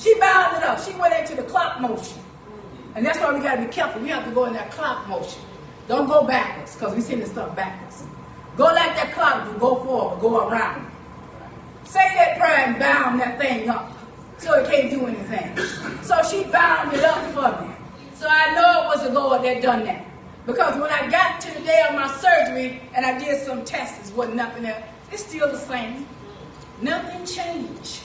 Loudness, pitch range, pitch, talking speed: -21 LUFS, 245-335 Hz, 280 Hz, 210 wpm